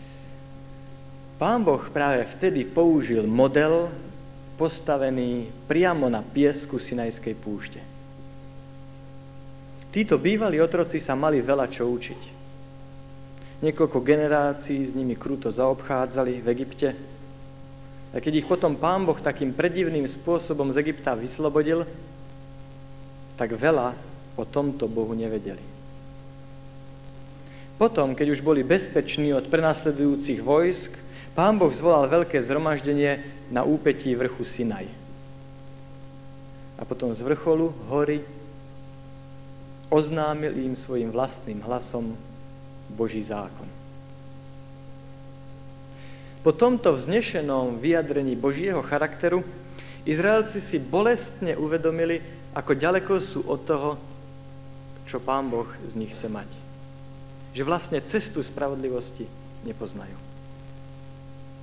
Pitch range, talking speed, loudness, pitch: 135-150 Hz, 100 wpm, -25 LUFS, 135 Hz